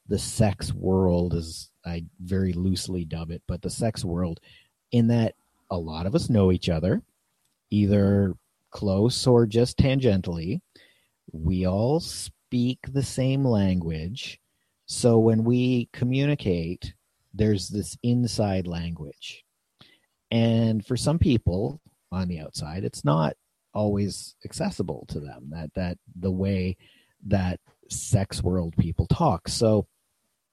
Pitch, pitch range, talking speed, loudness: 100 Hz, 90-115 Hz, 125 wpm, -25 LUFS